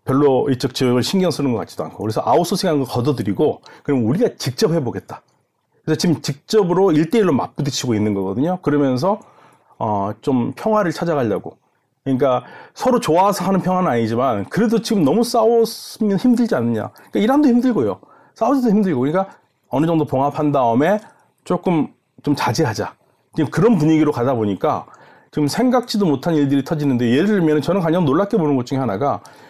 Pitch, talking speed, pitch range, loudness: 155 Hz, 405 characters per minute, 135-215 Hz, -18 LUFS